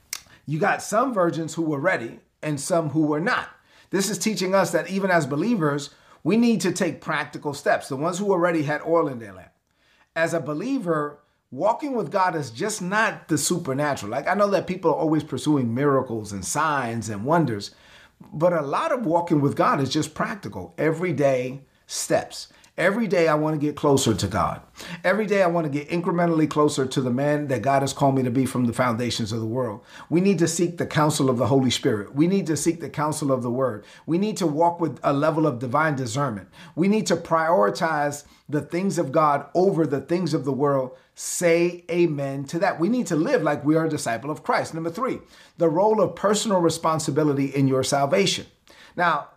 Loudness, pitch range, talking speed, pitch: -23 LUFS, 140-175 Hz, 210 wpm, 155 Hz